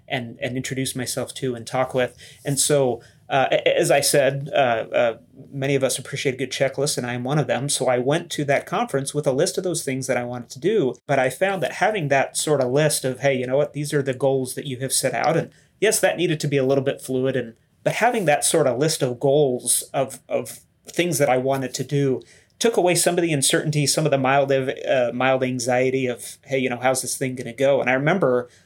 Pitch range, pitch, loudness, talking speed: 130-145 Hz, 135 Hz, -21 LUFS, 255 wpm